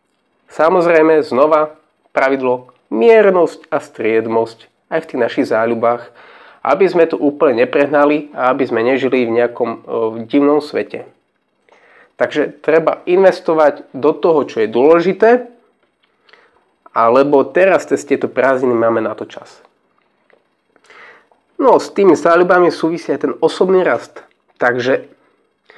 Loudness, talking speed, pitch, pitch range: -14 LUFS, 125 wpm, 150 Hz, 125-170 Hz